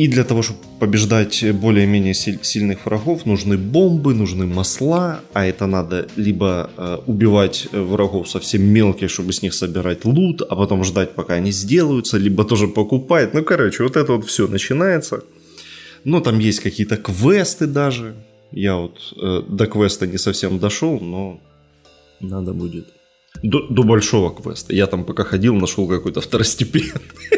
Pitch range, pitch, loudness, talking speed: 95-125 Hz, 105 Hz, -17 LUFS, 150 wpm